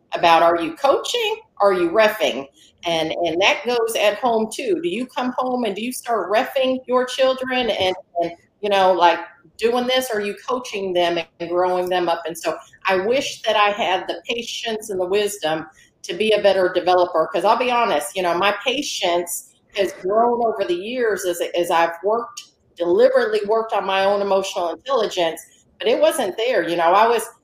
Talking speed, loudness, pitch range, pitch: 200 wpm, -20 LUFS, 175-240 Hz, 205 Hz